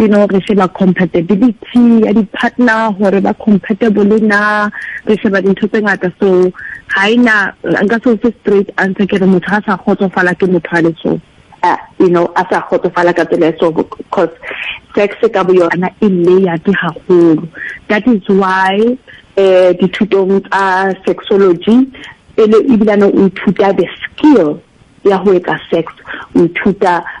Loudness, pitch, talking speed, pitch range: -11 LUFS, 195 Hz, 105 wpm, 185-215 Hz